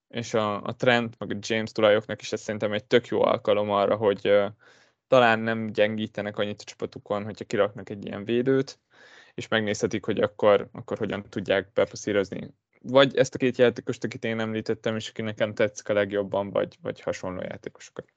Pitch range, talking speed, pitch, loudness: 105-125 Hz, 180 wpm, 115 Hz, -26 LUFS